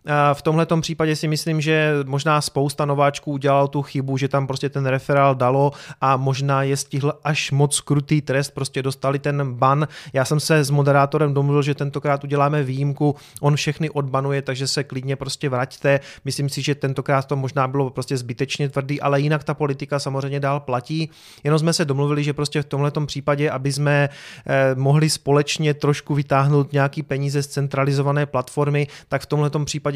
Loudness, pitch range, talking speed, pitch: -21 LUFS, 140-150 Hz, 180 wpm, 145 Hz